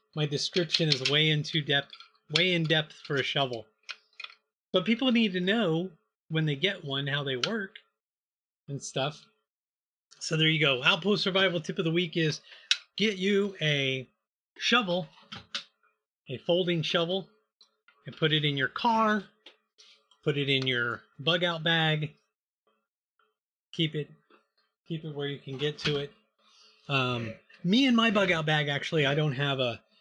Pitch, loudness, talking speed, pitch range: 155 Hz, -28 LUFS, 160 wpm, 140-185 Hz